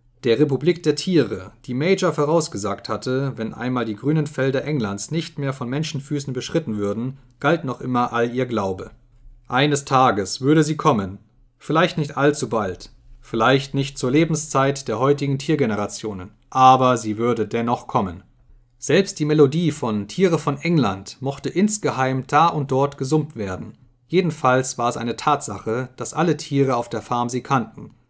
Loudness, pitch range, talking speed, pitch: -21 LUFS, 120-150 Hz, 160 wpm, 130 Hz